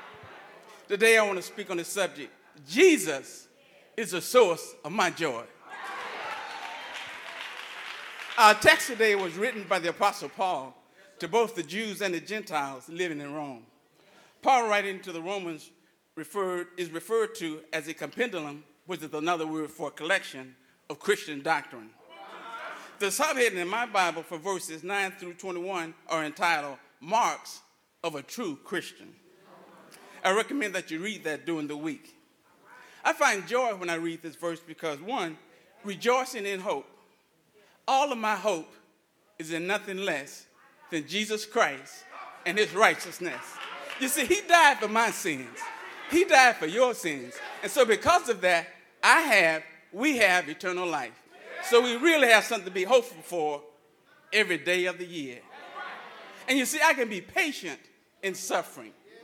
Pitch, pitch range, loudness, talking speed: 190 Hz, 165-230 Hz, -27 LUFS, 155 wpm